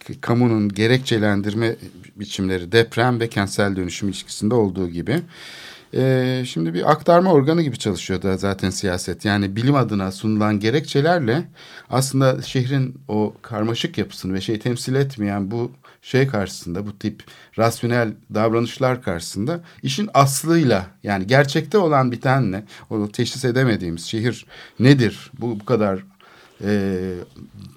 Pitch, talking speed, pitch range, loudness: 115 Hz, 125 wpm, 100-130 Hz, -20 LUFS